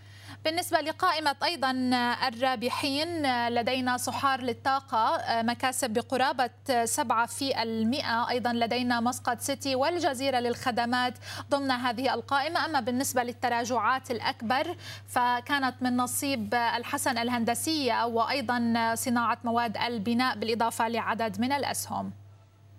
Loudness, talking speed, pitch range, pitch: -28 LUFS, 95 wpm, 235-270 Hz, 250 Hz